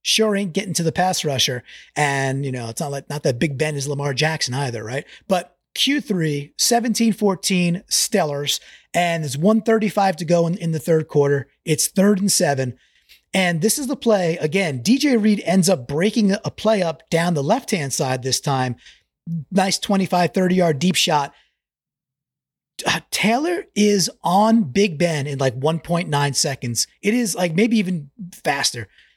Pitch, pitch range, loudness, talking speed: 170 Hz, 145-200 Hz, -20 LUFS, 175 wpm